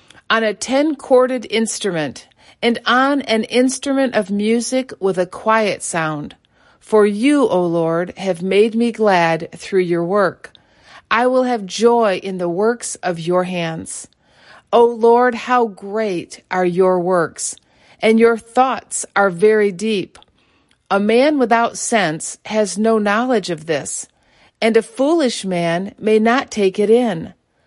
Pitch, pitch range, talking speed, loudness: 220 Hz, 185-235 Hz, 145 wpm, -17 LUFS